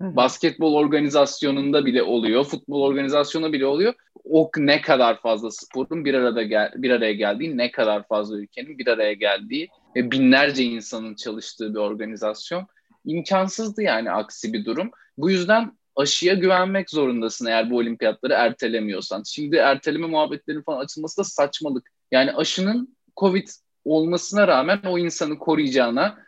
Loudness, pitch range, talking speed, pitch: -21 LUFS, 120-175 Hz, 140 wpm, 145 Hz